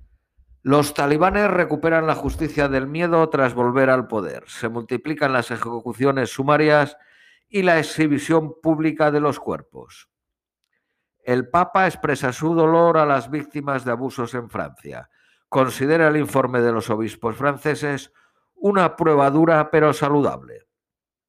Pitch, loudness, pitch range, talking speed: 145 Hz, -20 LUFS, 125-160 Hz, 135 wpm